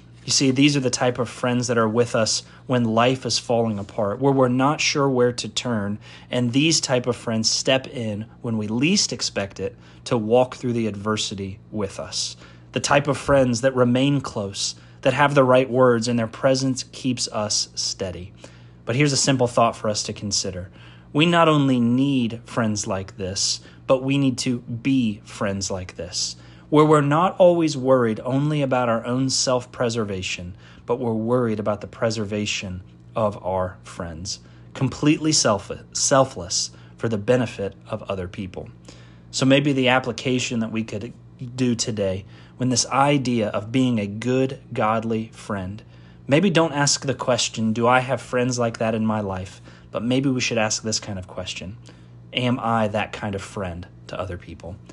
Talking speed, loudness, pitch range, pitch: 180 wpm, -22 LUFS, 100-130 Hz, 115 Hz